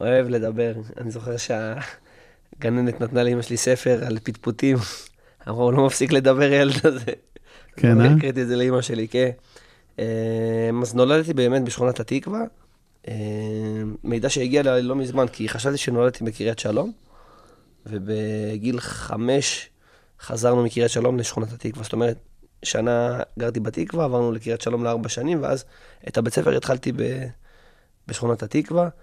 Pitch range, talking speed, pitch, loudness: 115-130 Hz, 130 wpm, 120 Hz, -22 LUFS